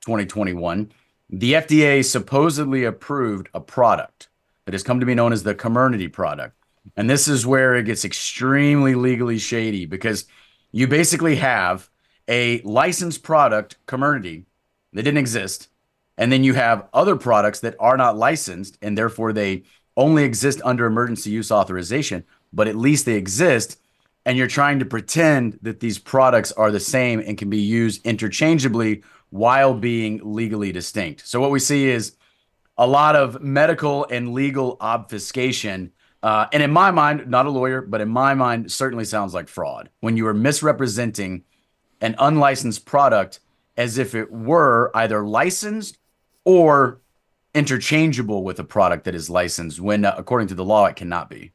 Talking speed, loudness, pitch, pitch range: 160 wpm, -19 LUFS, 120 Hz, 105-135 Hz